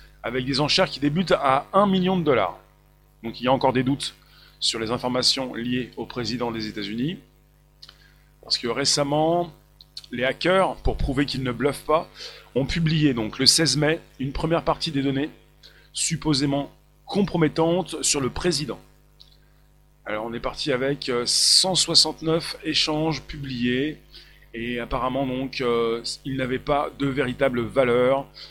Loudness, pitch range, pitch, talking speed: -23 LUFS, 125-155 Hz, 140 Hz, 145 wpm